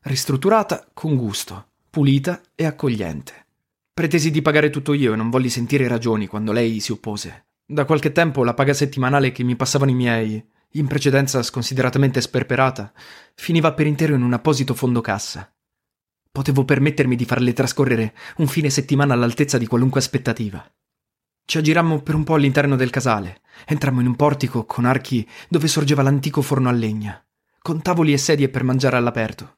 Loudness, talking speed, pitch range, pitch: -19 LUFS, 165 wpm, 120-150 Hz, 135 Hz